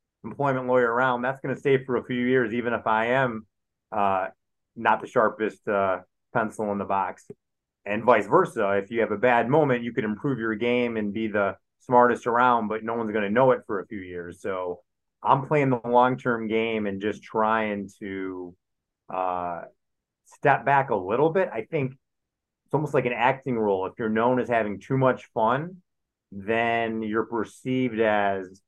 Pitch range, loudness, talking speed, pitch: 105-125 Hz, -25 LUFS, 190 wpm, 115 Hz